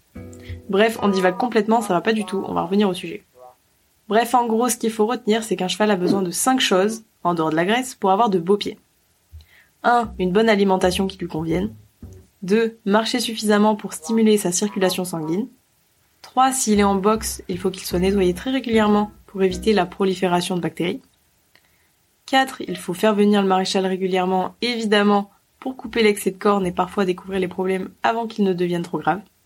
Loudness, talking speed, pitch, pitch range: -20 LUFS, 200 wpm, 195 Hz, 180-220 Hz